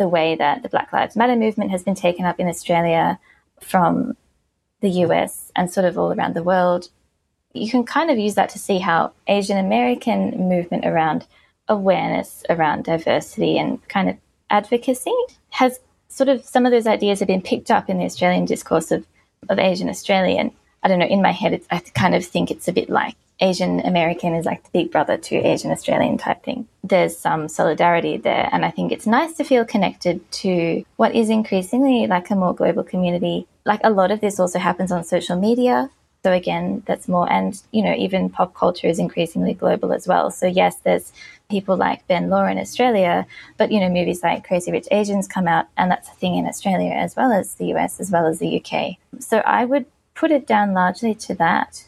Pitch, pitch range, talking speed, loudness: 195 Hz, 175-225 Hz, 210 wpm, -19 LUFS